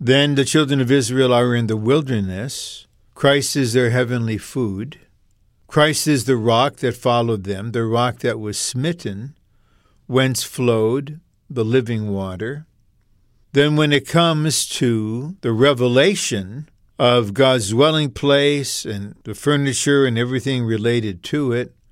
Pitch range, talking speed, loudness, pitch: 115-140 Hz, 135 wpm, -18 LUFS, 125 Hz